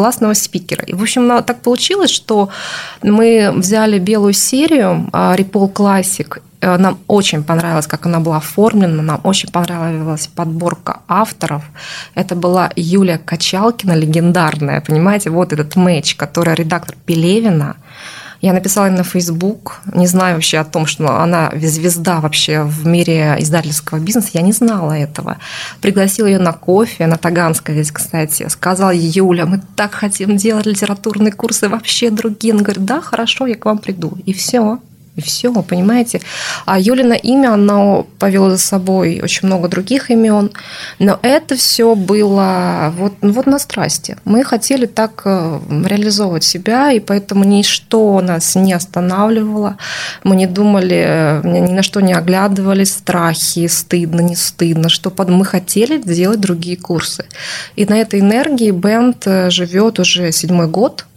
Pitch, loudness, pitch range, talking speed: 190 Hz, -13 LUFS, 170-210 Hz, 145 wpm